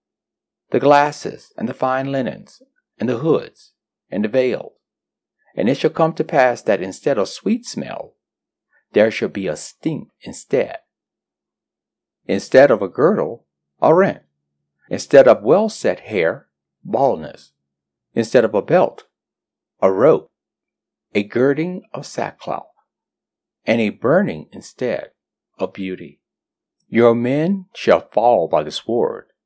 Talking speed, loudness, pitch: 130 wpm, -18 LUFS, 120 Hz